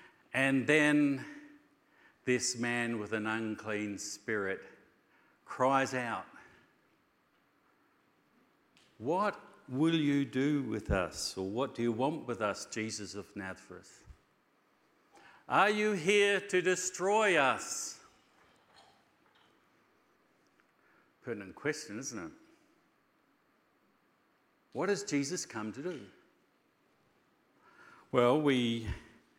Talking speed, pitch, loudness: 90 wpm, 130 Hz, -33 LUFS